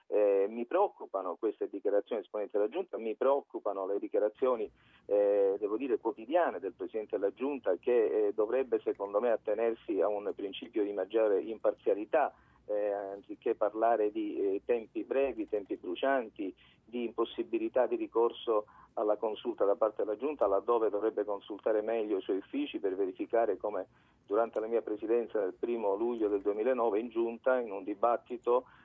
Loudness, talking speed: -33 LUFS, 155 wpm